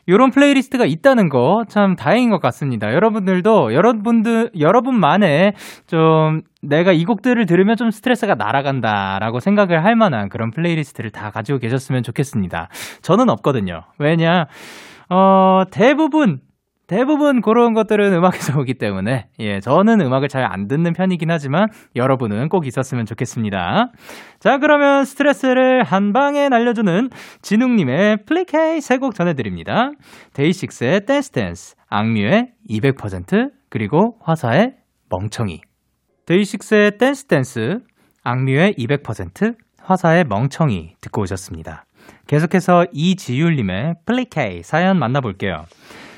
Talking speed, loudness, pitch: 315 characters per minute, -16 LUFS, 175 Hz